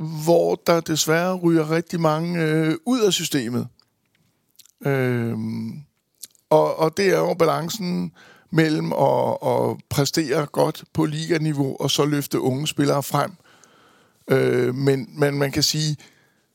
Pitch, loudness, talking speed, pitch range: 155 Hz, -21 LUFS, 130 wpm, 140-165 Hz